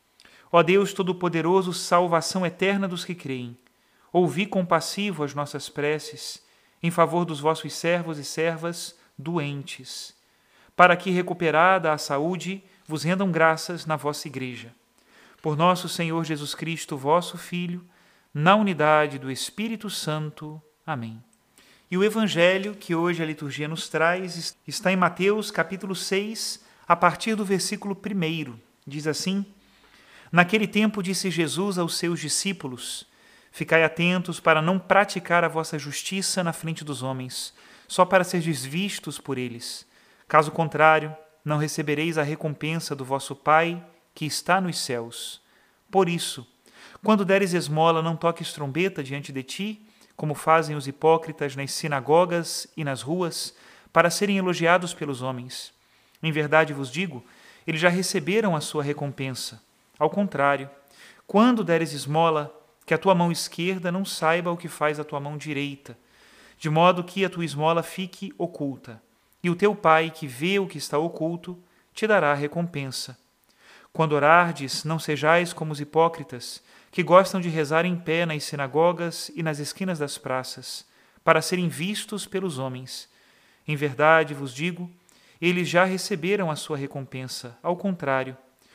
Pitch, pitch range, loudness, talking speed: 165 Hz, 150-180 Hz, -24 LUFS, 145 wpm